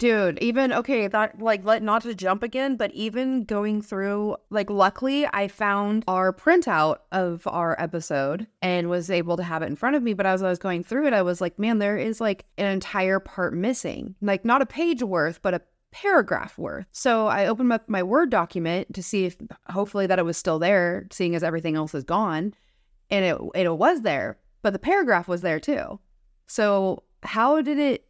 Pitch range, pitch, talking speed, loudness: 180-230 Hz, 200 Hz, 205 wpm, -24 LUFS